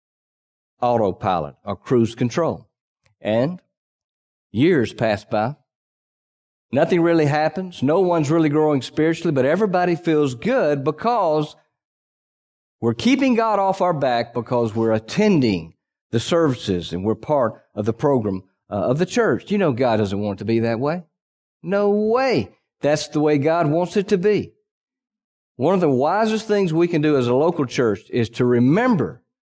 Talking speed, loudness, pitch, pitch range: 155 wpm, -20 LUFS, 155 Hz, 120-190 Hz